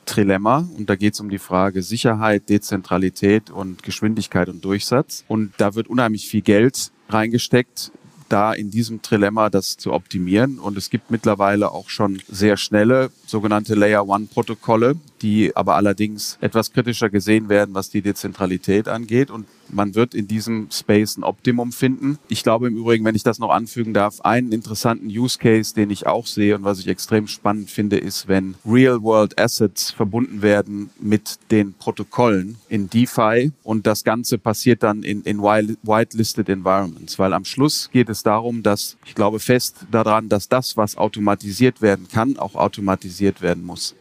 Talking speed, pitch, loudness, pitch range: 170 wpm, 110 Hz, -19 LUFS, 100-115 Hz